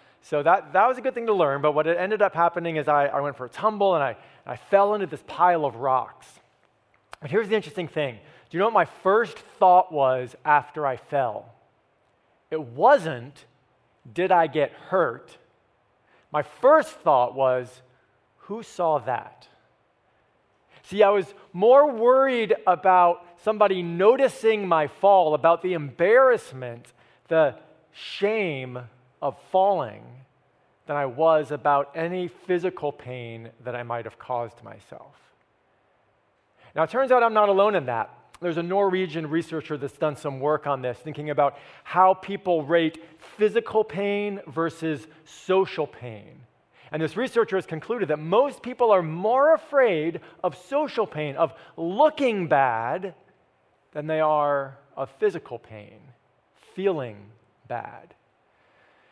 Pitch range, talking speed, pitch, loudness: 140-195 Hz, 145 wpm, 160 Hz, -23 LUFS